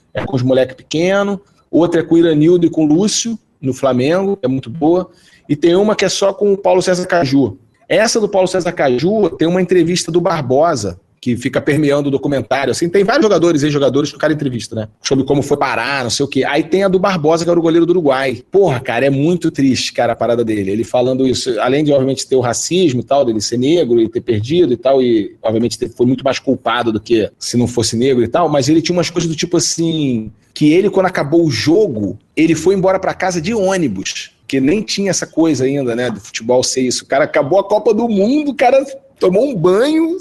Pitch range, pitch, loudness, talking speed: 130-185 Hz, 155 Hz, -14 LUFS, 240 wpm